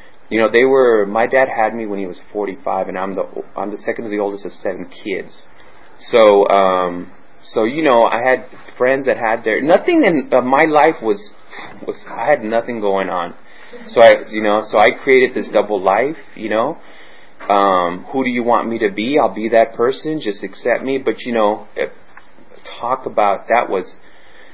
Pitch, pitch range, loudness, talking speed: 115 Hz, 100-135 Hz, -16 LUFS, 200 wpm